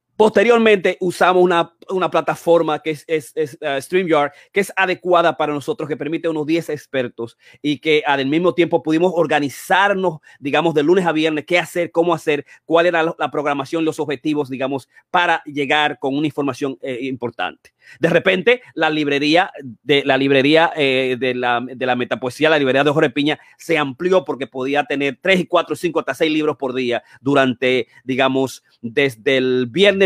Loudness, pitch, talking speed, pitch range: -18 LUFS, 150 Hz, 170 wpm, 135-170 Hz